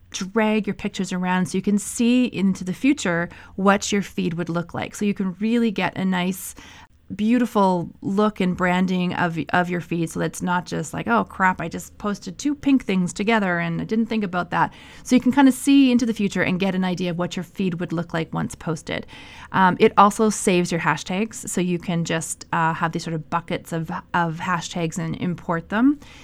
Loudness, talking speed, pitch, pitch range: -22 LUFS, 220 wpm, 185 Hz, 170-210 Hz